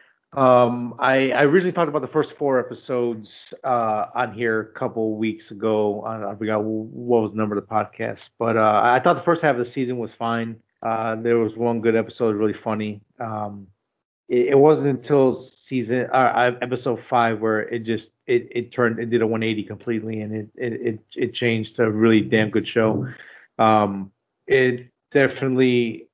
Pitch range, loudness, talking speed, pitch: 110-125 Hz, -21 LUFS, 190 wpm, 115 Hz